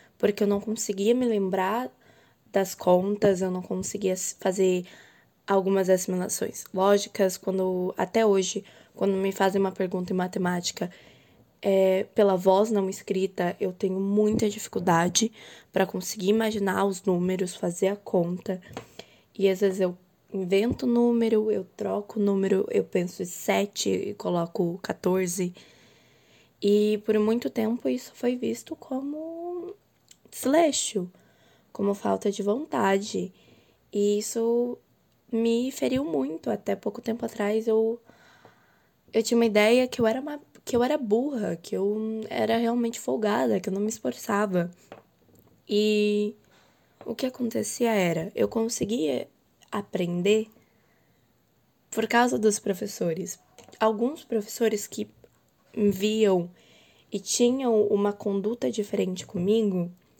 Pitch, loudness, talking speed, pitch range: 205 Hz, -26 LUFS, 125 wpm, 190-225 Hz